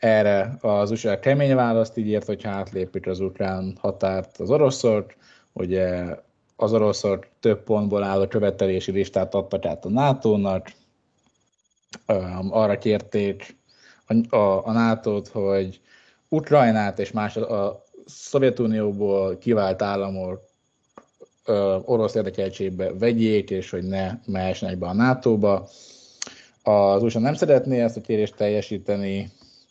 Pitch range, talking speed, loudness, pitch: 95-110 Hz, 120 wpm, -23 LUFS, 100 Hz